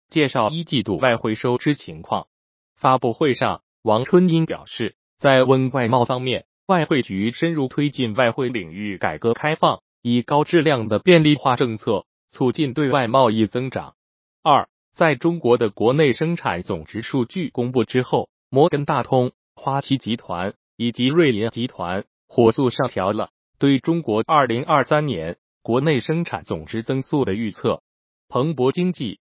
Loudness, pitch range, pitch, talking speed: -20 LUFS, 115-150 Hz, 130 Hz, 240 characters per minute